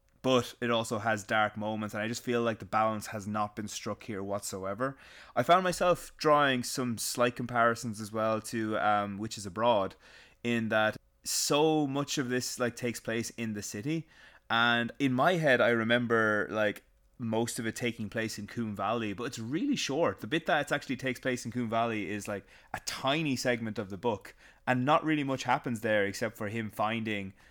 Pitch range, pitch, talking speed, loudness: 110-125 Hz, 115 Hz, 200 wpm, -31 LUFS